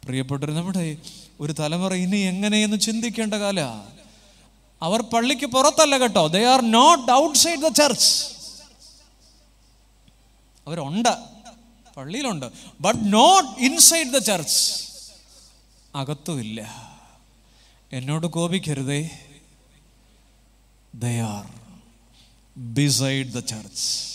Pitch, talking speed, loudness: 155 Hz, 80 wpm, -20 LUFS